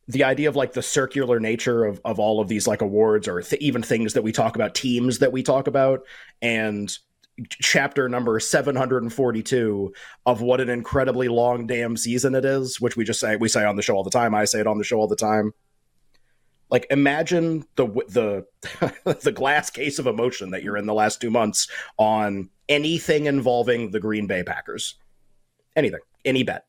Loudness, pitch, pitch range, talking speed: -22 LUFS, 120 Hz, 105-130 Hz, 195 wpm